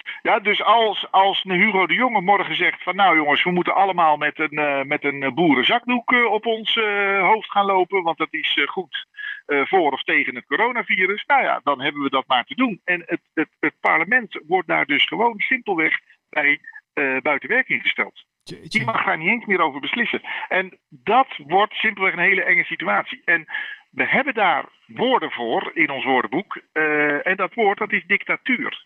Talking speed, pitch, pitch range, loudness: 200 wpm, 200 Hz, 175-245 Hz, -19 LUFS